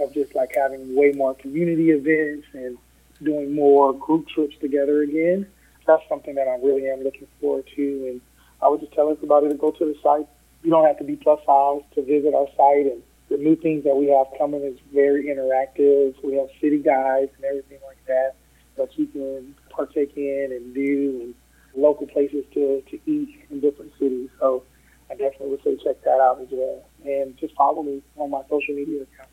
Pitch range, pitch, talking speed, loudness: 135-150 Hz, 140 Hz, 205 wpm, -22 LUFS